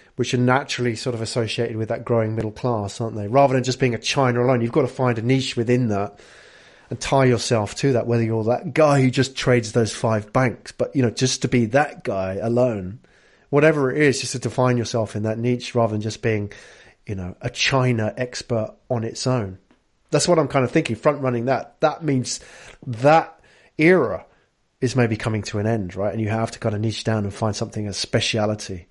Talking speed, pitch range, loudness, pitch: 220 wpm, 110-130 Hz, -21 LUFS, 120 Hz